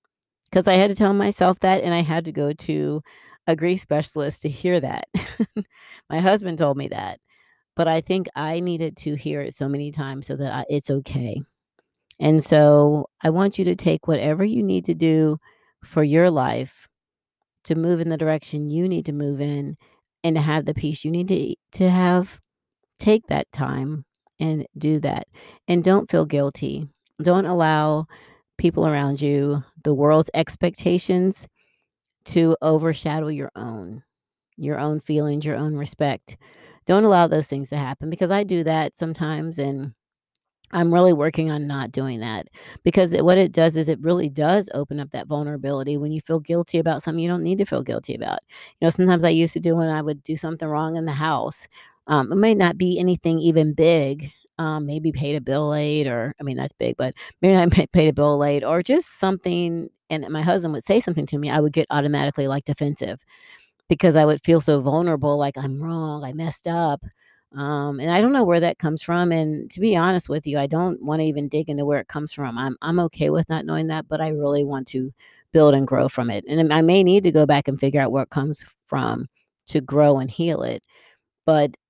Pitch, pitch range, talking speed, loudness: 155 Hz, 145-170 Hz, 205 wpm, -21 LUFS